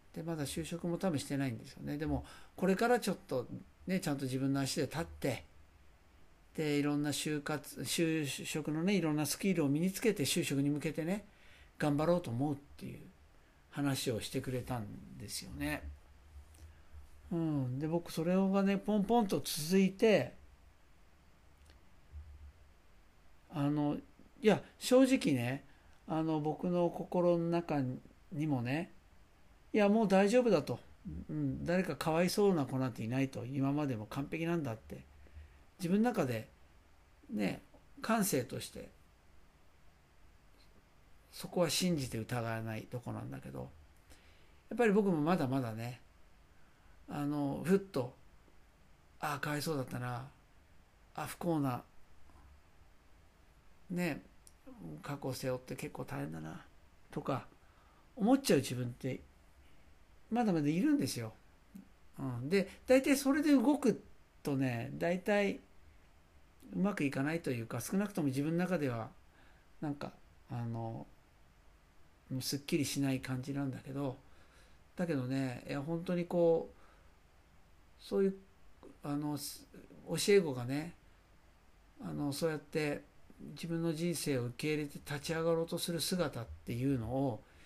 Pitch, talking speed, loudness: 135 Hz, 240 characters per minute, -35 LUFS